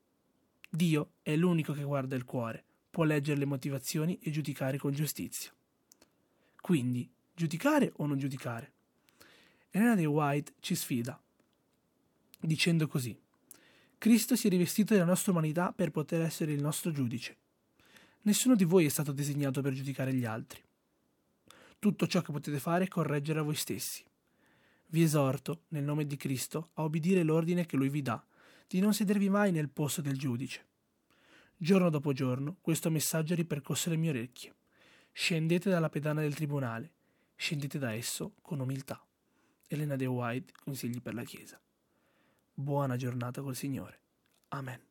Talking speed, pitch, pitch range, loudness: 150 wpm, 150 Hz, 140-175 Hz, -32 LUFS